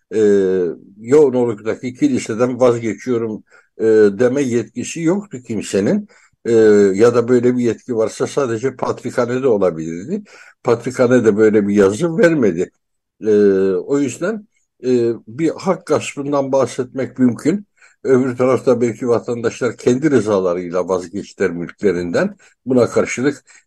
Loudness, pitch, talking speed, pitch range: -17 LUFS, 120 Hz, 100 wpm, 110-135 Hz